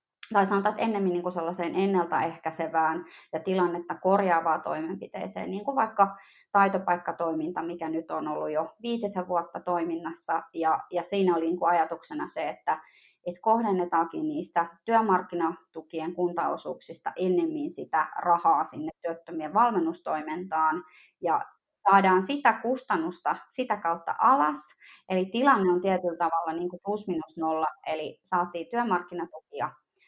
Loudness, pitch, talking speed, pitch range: -28 LUFS, 175 Hz, 125 wpm, 165-200 Hz